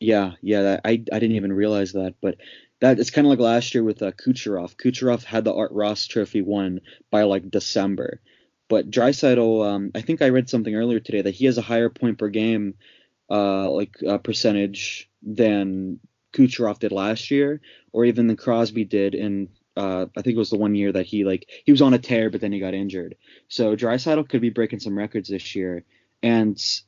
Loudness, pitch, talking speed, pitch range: -22 LUFS, 110 Hz, 210 wpm, 100-115 Hz